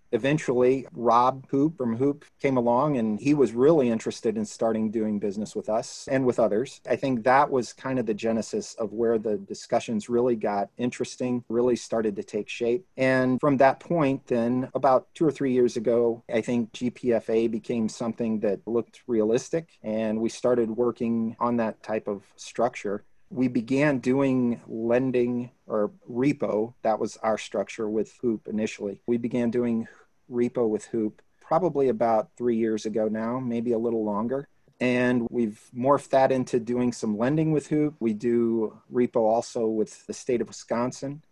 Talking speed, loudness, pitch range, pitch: 170 wpm, -26 LUFS, 115-130 Hz, 120 Hz